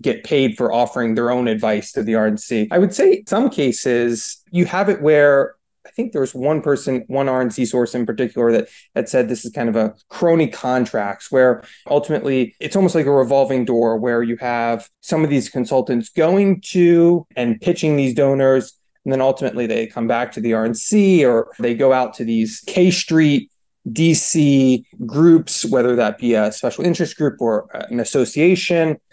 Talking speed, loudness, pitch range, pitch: 185 wpm, -17 LUFS, 120-160 Hz, 130 Hz